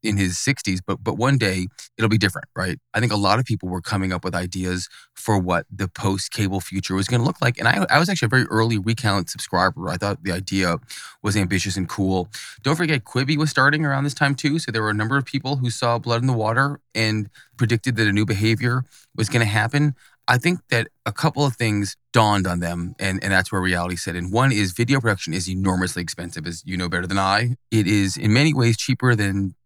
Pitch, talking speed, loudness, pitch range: 110 Hz, 240 wpm, -21 LUFS, 95-125 Hz